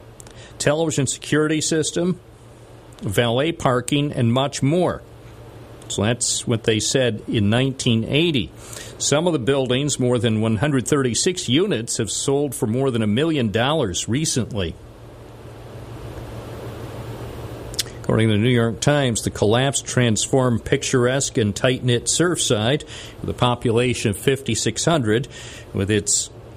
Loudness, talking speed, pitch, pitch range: -20 LUFS, 120 wpm, 120 Hz, 115-135 Hz